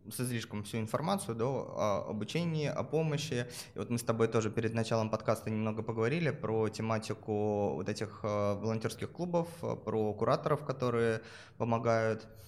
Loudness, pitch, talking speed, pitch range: -34 LUFS, 115 Hz, 150 wpm, 110-125 Hz